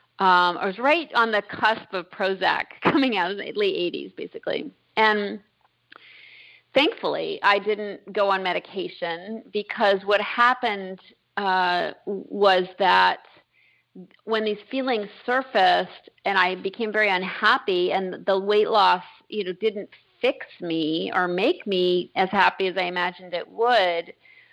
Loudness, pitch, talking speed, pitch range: -23 LUFS, 205 Hz, 140 wpm, 185-240 Hz